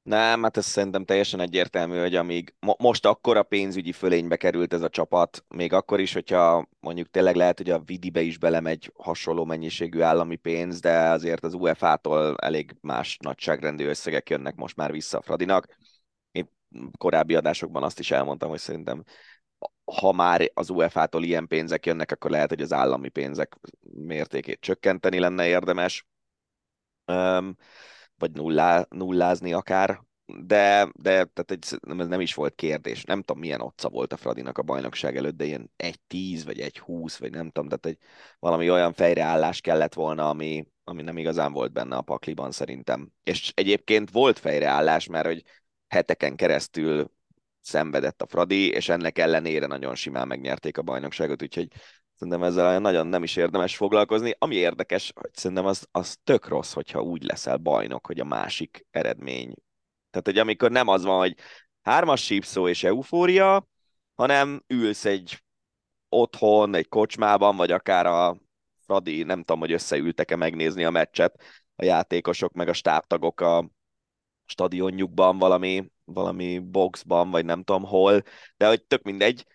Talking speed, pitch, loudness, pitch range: 160 wpm, 90 Hz, -24 LUFS, 80-95 Hz